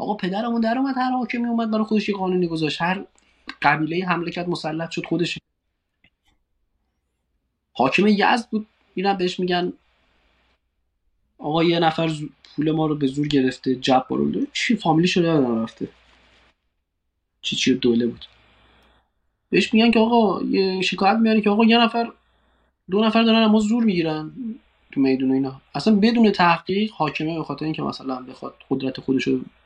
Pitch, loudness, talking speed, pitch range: 165 Hz, -21 LUFS, 155 wpm, 130-210 Hz